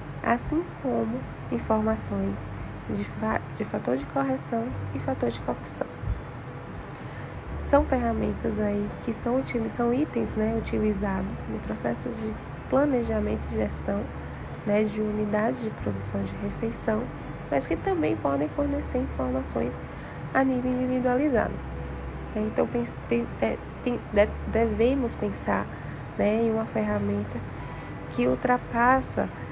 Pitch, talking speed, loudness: 205 Hz, 105 wpm, -28 LUFS